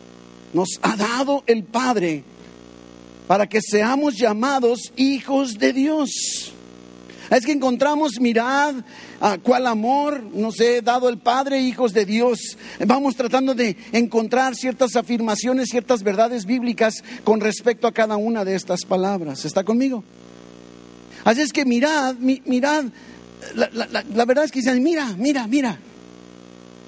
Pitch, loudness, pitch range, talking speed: 235 Hz, -20 LUFS, 190-260 Hz, 135 wpm